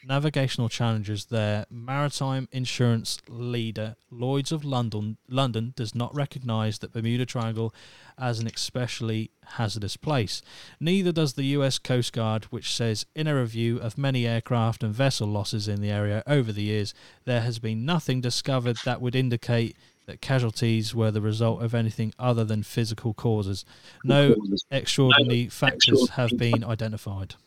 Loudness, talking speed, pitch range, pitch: -26 LUFS, 150 wpm, 110-130 Hz, 120 Hz